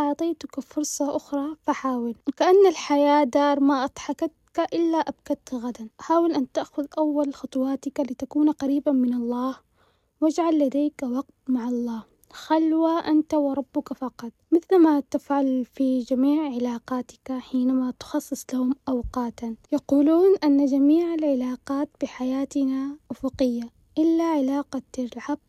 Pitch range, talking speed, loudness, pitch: 260-300 Hz, 115 wpm, -24 LUFS, 280 Hz